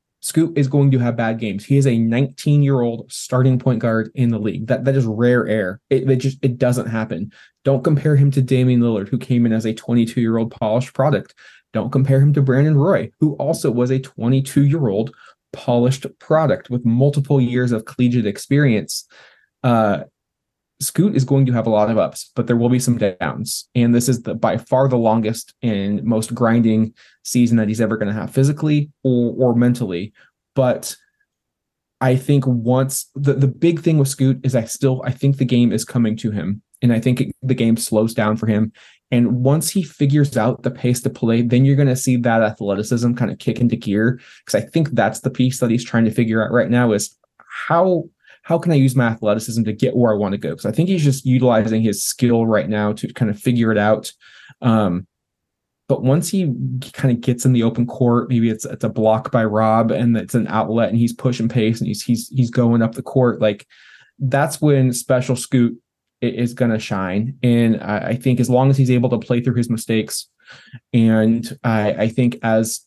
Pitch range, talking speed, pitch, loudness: 115-135 Hz, 215 wpm, 120 Hz, -18 LUFS